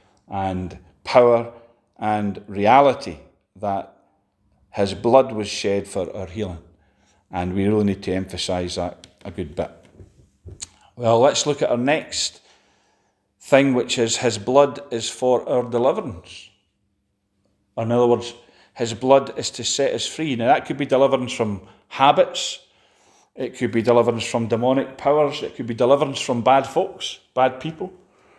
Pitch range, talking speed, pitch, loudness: 100-125 Hz, 150 wpm, 115 Hz, -20 LUFS